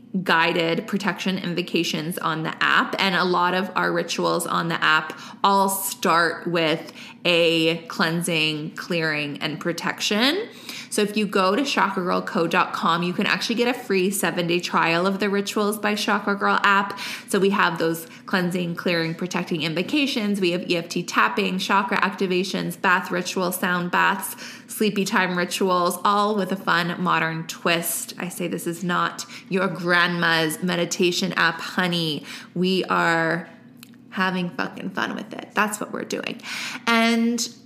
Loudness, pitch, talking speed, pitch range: -22 LUFS, 185 Hz, 150 wpm, 170-205 Hz